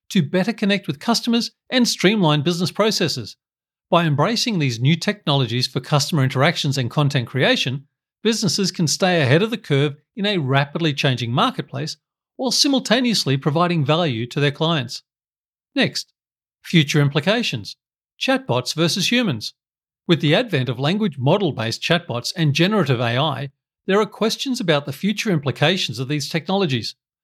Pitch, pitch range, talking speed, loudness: 160 Hz, 140-195 Hz, 145 wpm, -19 LUFS